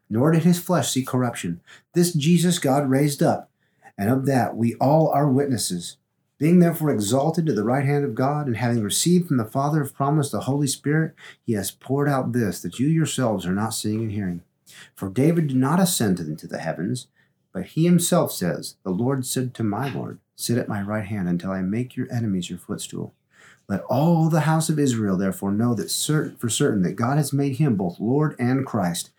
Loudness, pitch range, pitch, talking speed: -22 LUFS, 110-150 Hz, 130 Hz, 210 wpm